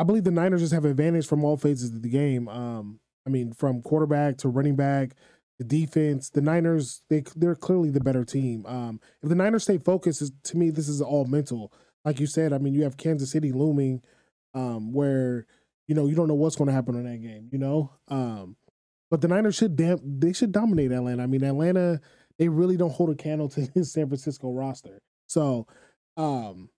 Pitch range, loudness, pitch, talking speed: 130-160 Hz, -26 LUFS, 145 Hz, 210 wpm